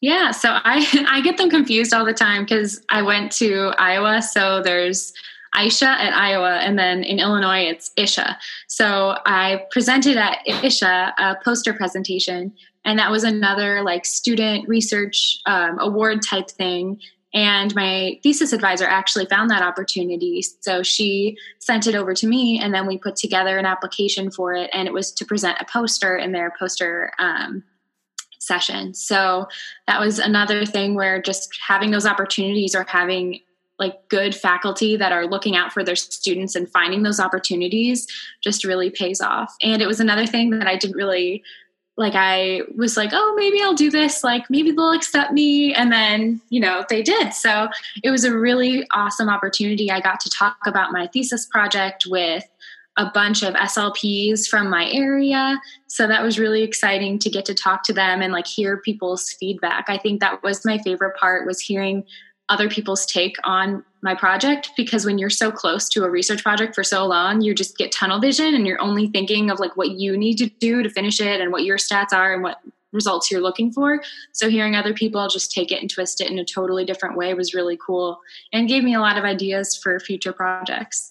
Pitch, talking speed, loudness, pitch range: 200 Hz, 195 wpm, -19 LUFS, 190-220 Hz